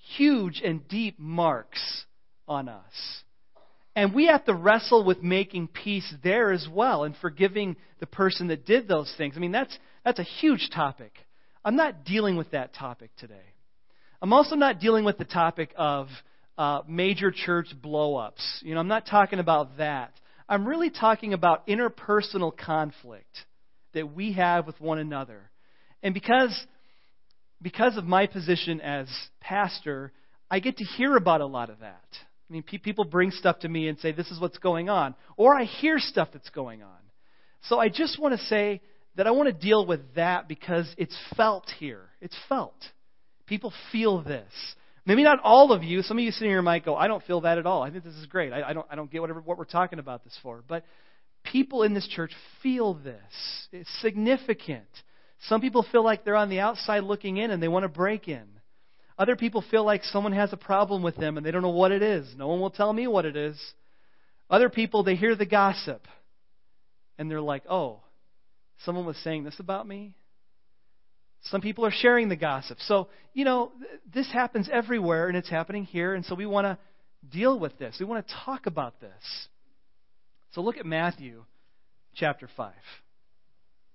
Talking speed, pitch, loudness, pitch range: 195 wpm, 180 Hz, -26 LUFS, 155-210 Hz